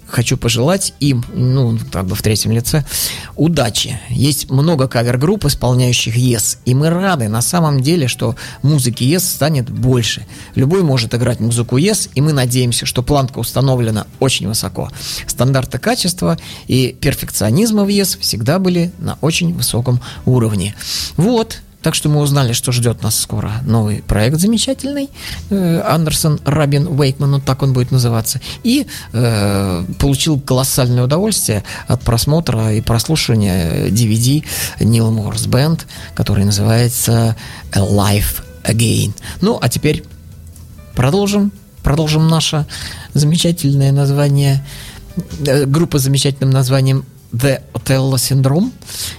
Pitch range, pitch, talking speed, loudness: 115-150 Hz, 130 Hz, 130 wpm, -15 LUFS